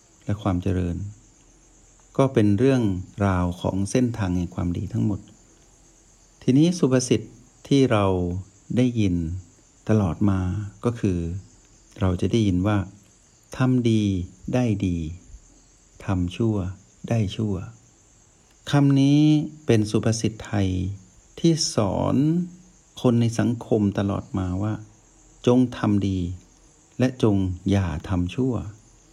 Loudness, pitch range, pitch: -23 LUFS, 95-125 Hz, 105 Hz